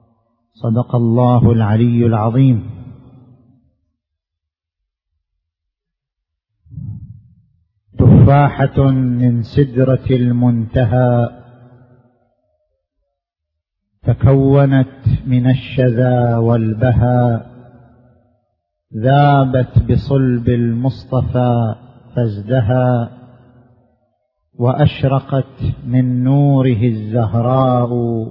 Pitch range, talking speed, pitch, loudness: 115-130 Hz, 40 wpm, 120 Hz, -14 LUFS